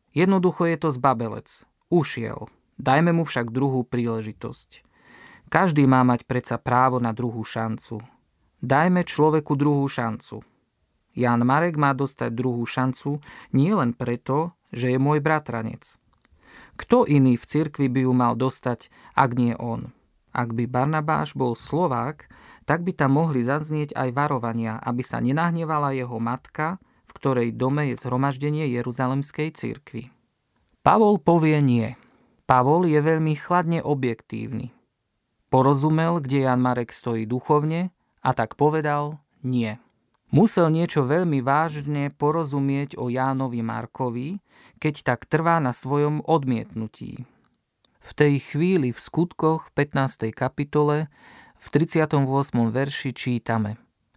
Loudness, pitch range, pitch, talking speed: -23 LUFS, 120-155 Hz, 135 Hz, 125 wpm